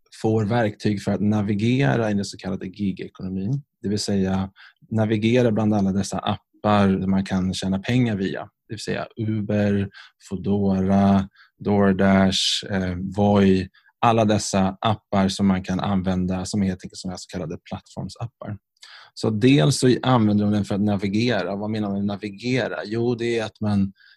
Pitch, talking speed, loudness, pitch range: 100 Hz, 160 wpm, -22 LUFS, 95-110 Hz